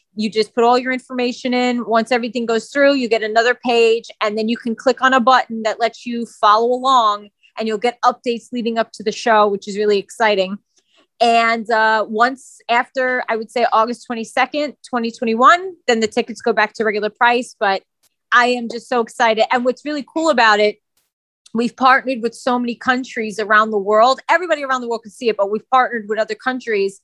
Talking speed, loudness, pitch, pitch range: 205 wpm, -17 LUFS, 235 Hz, 220-255 Hz